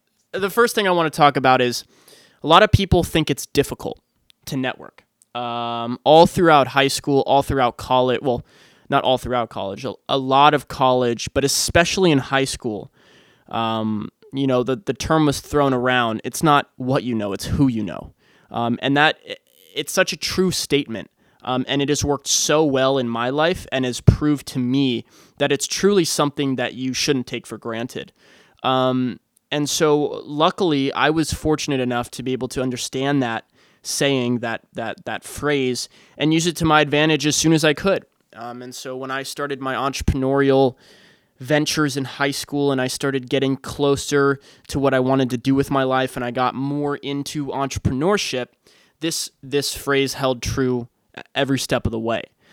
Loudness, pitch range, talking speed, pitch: -20 LUFS, 125-145 Hz, 185 wpm, 135 Hz